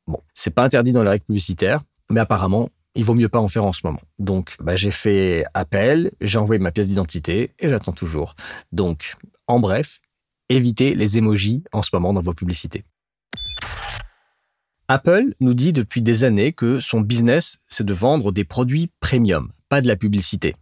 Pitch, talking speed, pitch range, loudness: 110 Hz, 185 wpm, 95-120 Hz, -19 LUFS